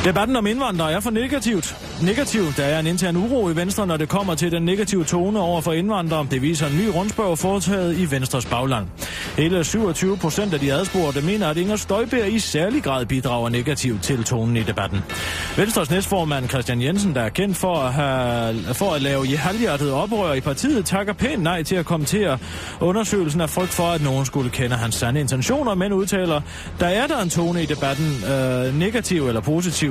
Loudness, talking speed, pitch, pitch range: -21 LUFS, 200 wpm, 170 Hz, 135-195 Hz